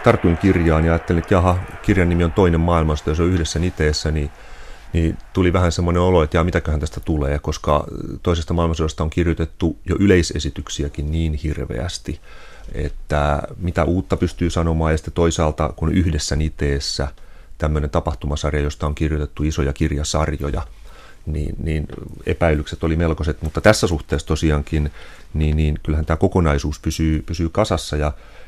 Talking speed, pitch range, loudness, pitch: 150 wpm, 75-85 Hz, -20 LUFS, 80 Hz